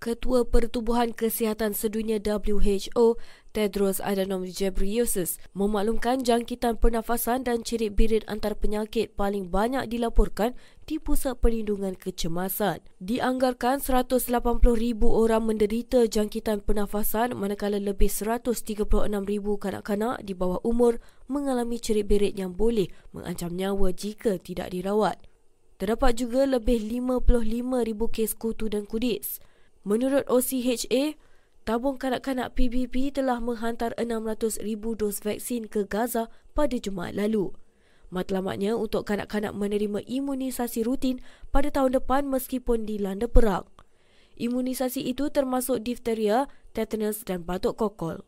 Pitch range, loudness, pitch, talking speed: 205-245 Hz, -27 LUFS, 225 Hz, 110 wpm